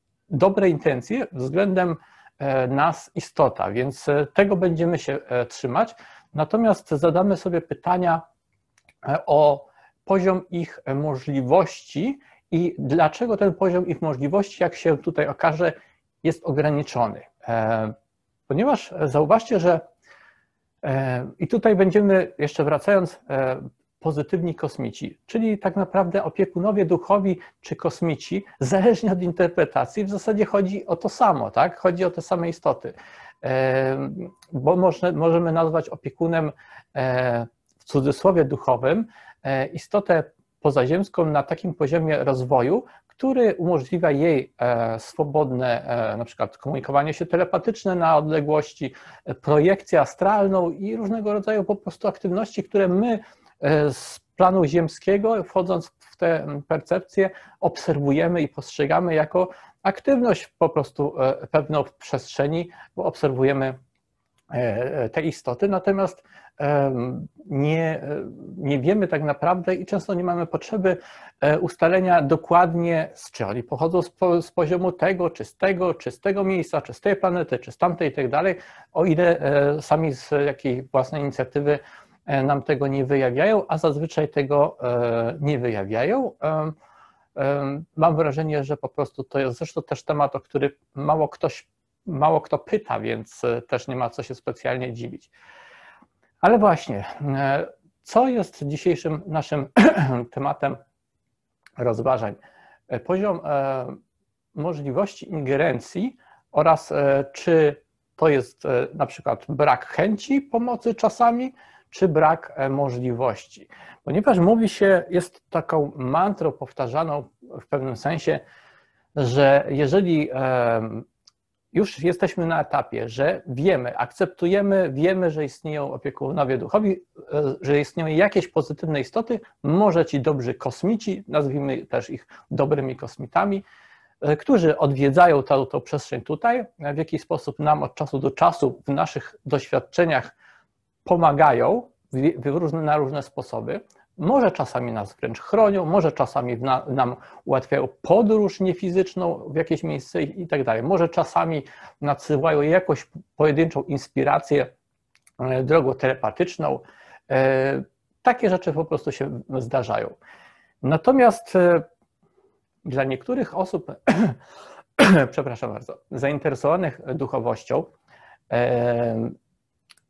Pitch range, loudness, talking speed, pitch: 140-185 Hz, -22 LUFS, 115 wpm, 160 Hz